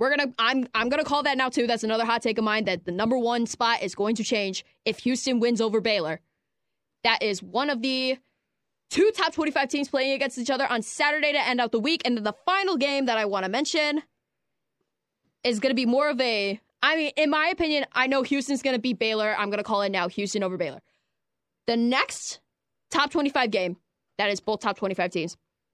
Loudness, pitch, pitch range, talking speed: -25 LUFS, 245 Hz, 215-280 Hz, 235 wpm